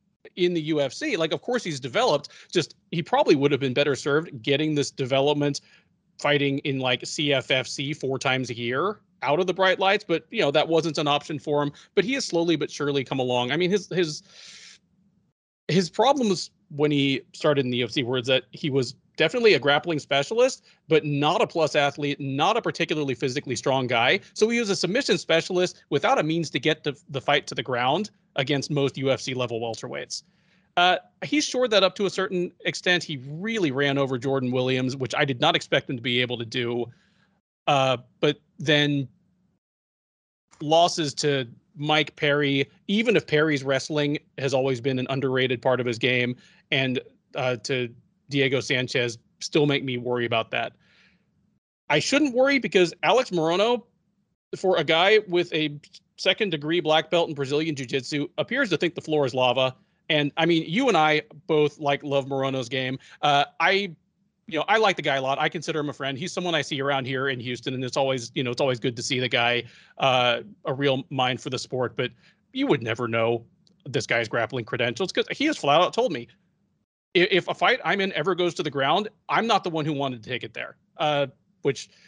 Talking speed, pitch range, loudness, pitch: 200 wpm, 135-175 Hz, -24 LUFS, 145 Hz